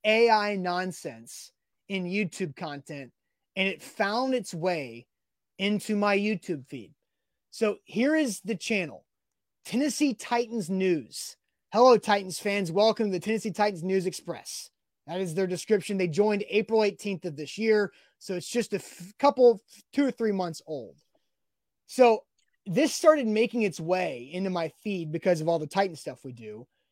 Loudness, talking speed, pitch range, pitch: -27 LUFS, 160 wpm, 175-220 Hz, 200 Hz